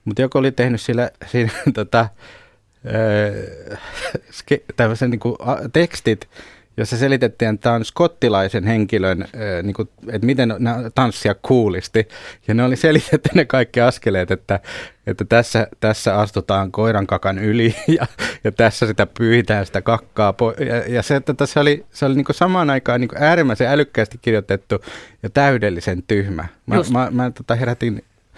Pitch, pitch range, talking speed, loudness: 115 Hz, 105-125 Hz, 150 wpm, -18 LUFS